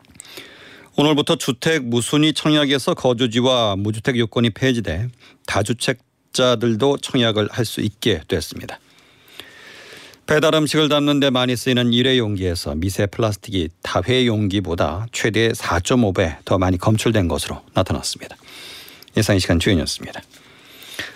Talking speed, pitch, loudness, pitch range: 300 characters per minute, 120 Hz, -19 LUFS, 100-130 Hz